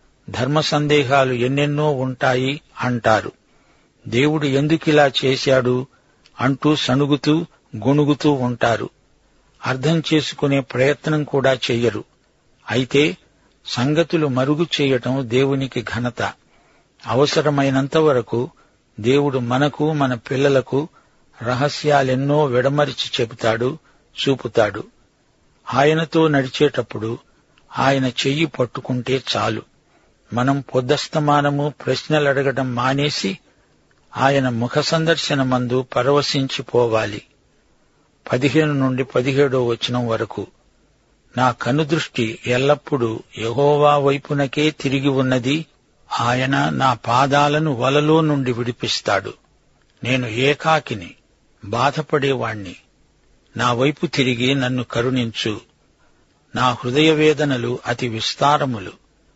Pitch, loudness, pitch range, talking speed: 135 Hz, -19 LUFS, 125-145 Hz, 80 wpm